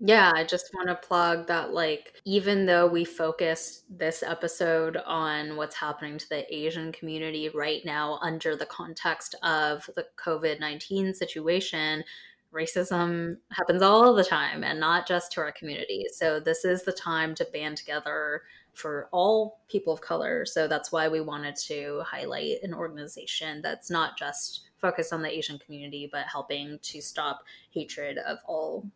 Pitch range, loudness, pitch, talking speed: 155-180 Hz, -28 LUFS, 165 Hz, 165 wpm